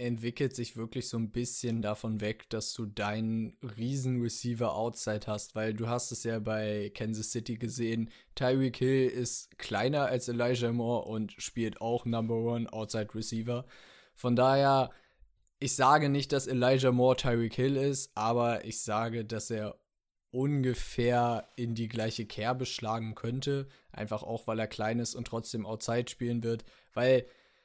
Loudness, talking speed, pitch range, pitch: -32 LUFS, 155 wpm, 110-125 Hz, 120 Hz